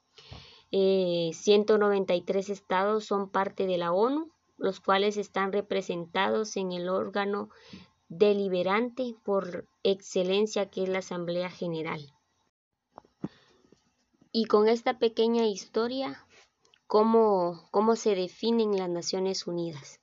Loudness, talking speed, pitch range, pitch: -28 LUFS, 110 wpm, 185-220 Hz, 200 Hz